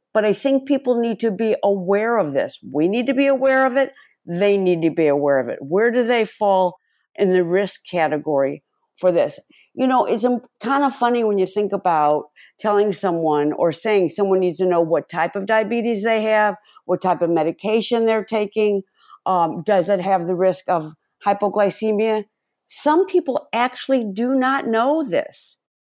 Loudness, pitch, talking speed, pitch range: -19 LUFS, 210 Hz, 185 wpm, 185-240 Hz